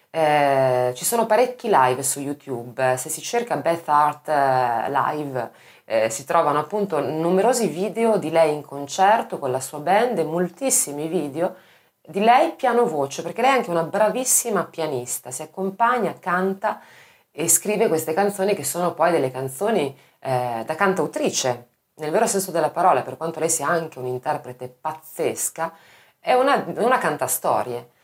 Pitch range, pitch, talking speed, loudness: 140-200 Hz, 160 Hz, 155 wpm, -21 LUFS